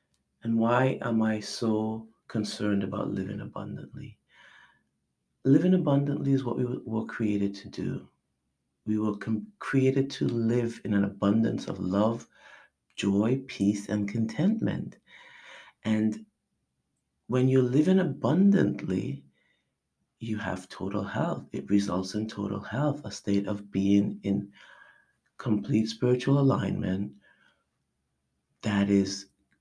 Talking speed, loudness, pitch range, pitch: 115 wpm, -28 LUFS, 100-125 Hz, 105 Hz